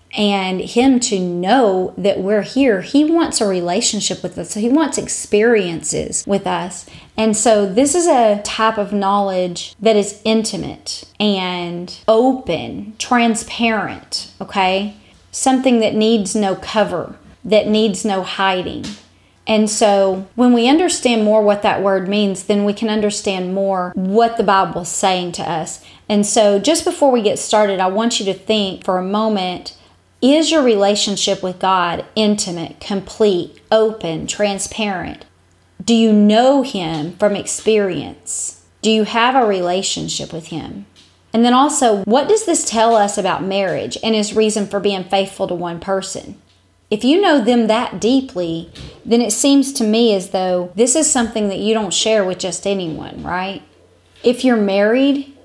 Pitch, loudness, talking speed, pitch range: 210 Hz, -16 LUFS, 160 wpm, 190-230 Hz